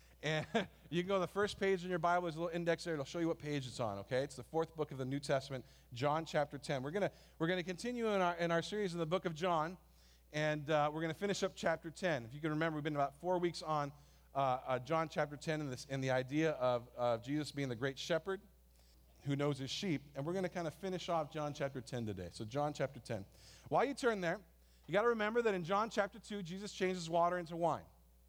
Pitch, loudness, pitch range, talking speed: 155 Hz, -38 LUFS, 135-180 Hz, 265 wpm